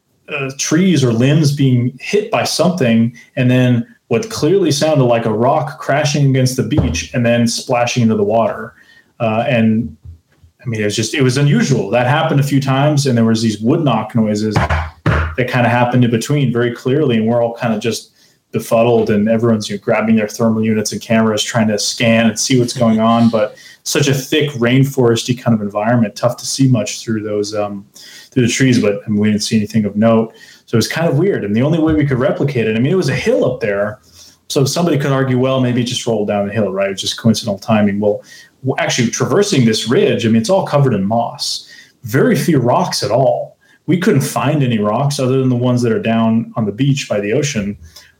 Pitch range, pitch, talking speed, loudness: 110-135 Hz, 120 Hz, 225 wpm, -15 LUFS